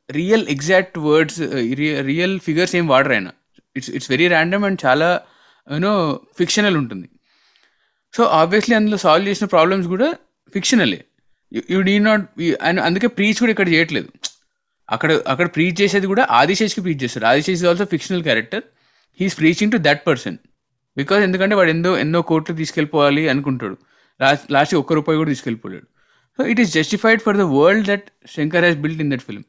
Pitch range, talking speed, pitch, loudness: 150-200 Hz, 155 wpm, 175 Hz, -17 LUFS